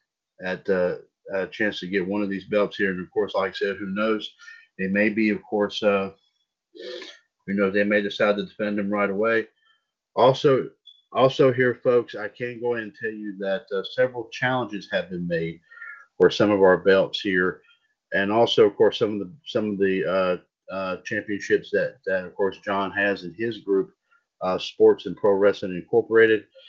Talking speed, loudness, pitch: 195 wpm, -23 LUFS, 110 Hz